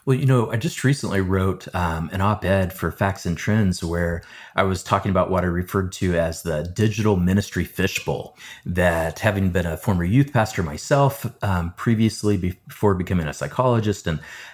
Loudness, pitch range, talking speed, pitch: -22 LUFS, 90-110 Hz, 185 wpm, 95 Hz